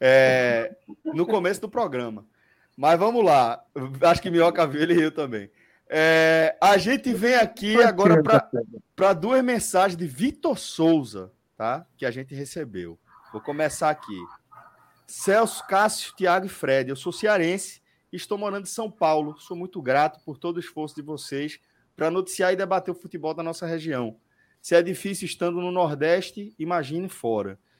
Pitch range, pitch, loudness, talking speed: 150-190 Hz, 170 Hz, -23 LUFS, 160 wpm